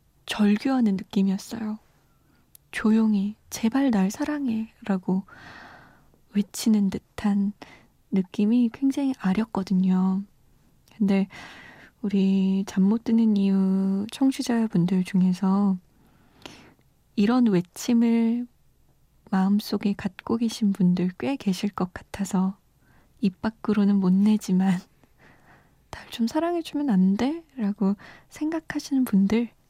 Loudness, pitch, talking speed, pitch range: -24 LUFS, 205 Hz, 210 characters per minute, 195-230 Hz